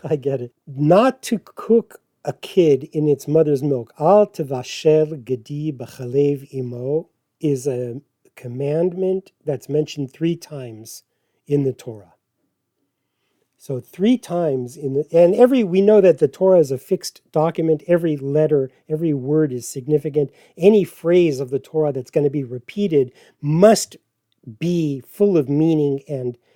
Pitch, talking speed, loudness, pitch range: 150 Hz, 145 wpm, -19 LUFS, 135-170 Hz